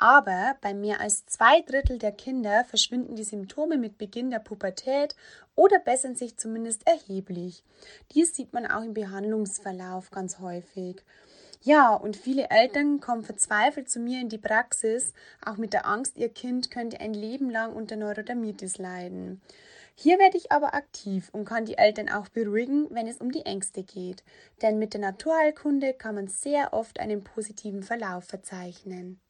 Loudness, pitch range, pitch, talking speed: -26 LUFS, 200-260 Hz, 220 Hz, 165 wpm